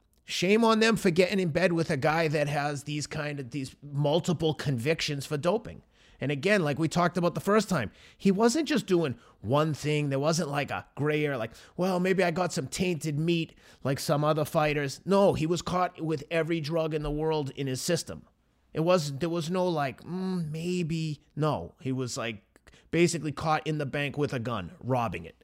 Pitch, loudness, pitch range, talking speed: 155 Hz, -28 LUFS, 145-175 Hz, 210 wpm